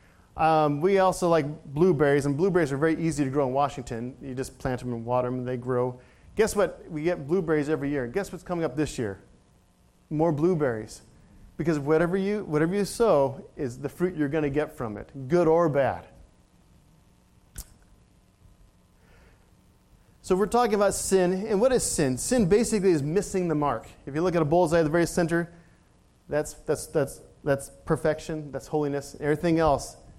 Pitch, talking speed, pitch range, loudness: 155 Hz, 180 wpm, 135-175 Hz, -26 LUFS